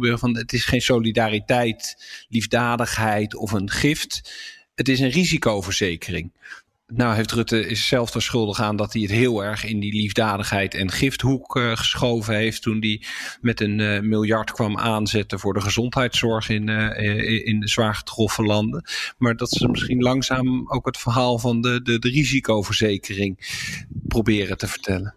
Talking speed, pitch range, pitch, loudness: 160 wpm, 105-125 Hz, 115 Hz, -22 LUFS